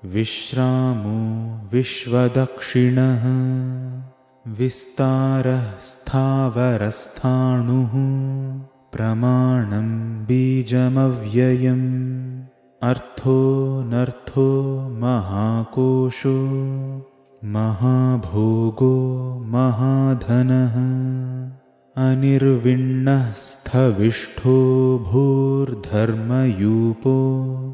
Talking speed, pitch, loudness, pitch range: 30 wpm, 130 Hz, -20 LUFS, 120-130 Hz